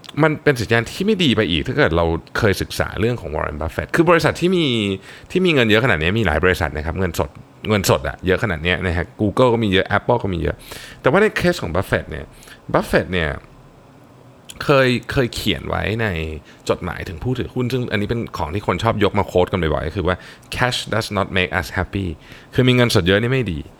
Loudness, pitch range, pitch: -19 LUFS, 90-125 Hz, 105 Hz